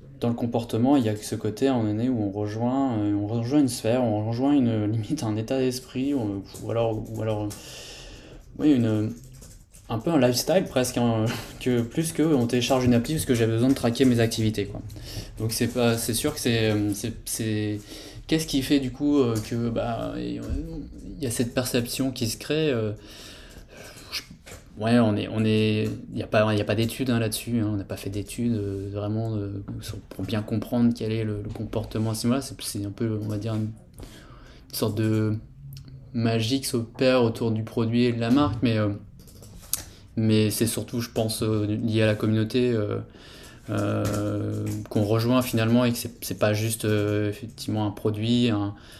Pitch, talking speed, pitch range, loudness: 115 Hz, 190 wpm, 105-120 Hz, -25 LUFS